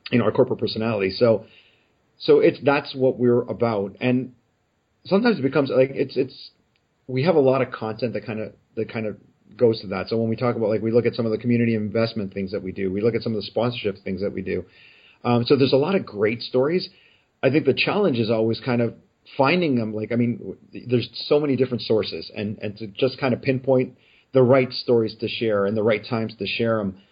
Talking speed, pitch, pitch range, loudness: 240 wpm, 115 Hz, 110-130 Hz, -22 LUFS